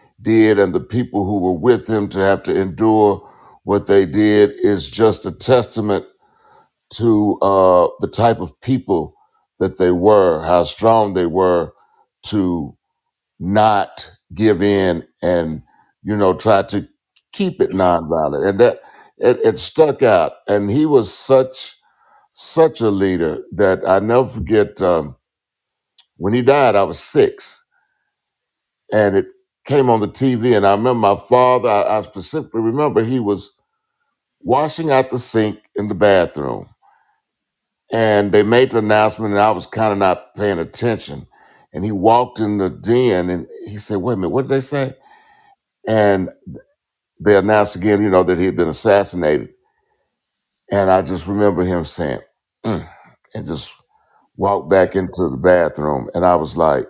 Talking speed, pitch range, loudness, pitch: 160 wpm, 95-135 Hz, -16 LUFS, 110 Hz